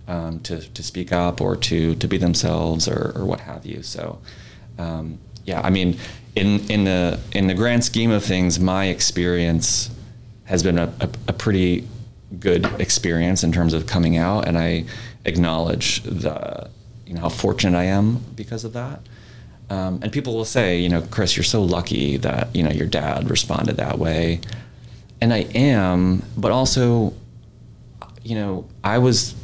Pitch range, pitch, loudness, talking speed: 90-115 Hz, 100 Hz, -20 LUFS, 175 wpm